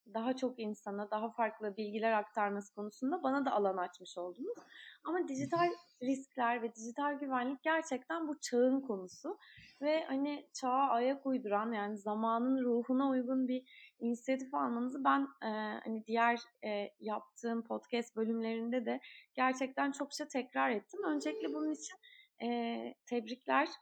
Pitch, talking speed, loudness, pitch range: 250 Hz, 135 wpm, -37 LUFS, 220-280 Hz